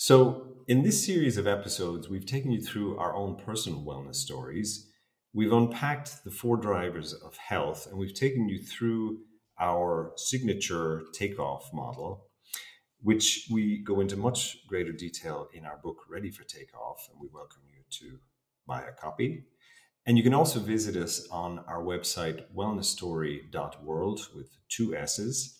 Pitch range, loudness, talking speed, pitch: 85-115 Hz, -30 LUFS, 150 wpm, 100 Hz